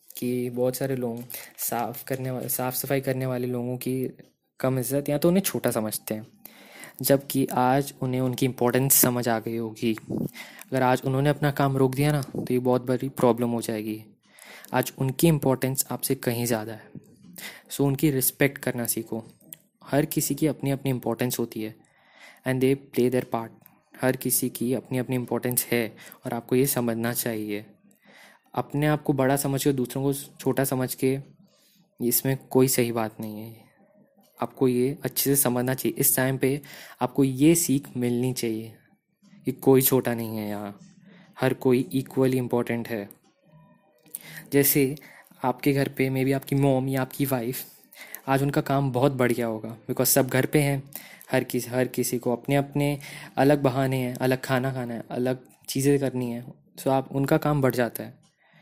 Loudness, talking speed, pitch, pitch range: -25 LUFS, 175 wpm, 130 Hz, 125-140 Hz